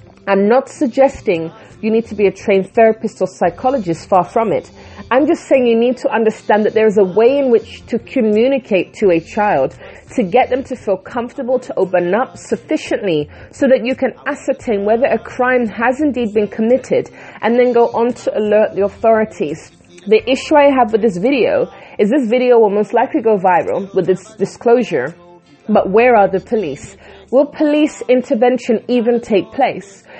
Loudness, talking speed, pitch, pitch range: -15 LUFS, 185 wpm, 230 Hz, 205-255 Hz